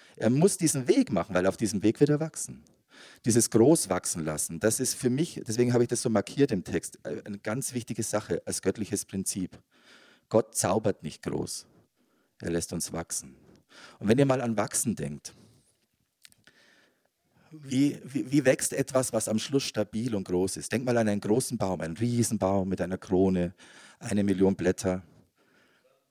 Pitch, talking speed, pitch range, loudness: 110 Hz, 175 wpm, 95-125 Hz, -28 LUFS